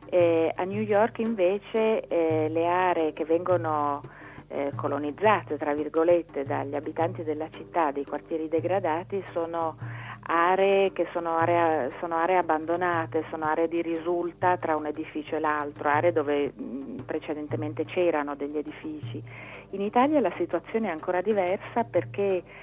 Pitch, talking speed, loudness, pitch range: 165 Hz, 140 wpm, -27 LUFS, 150-180 Hz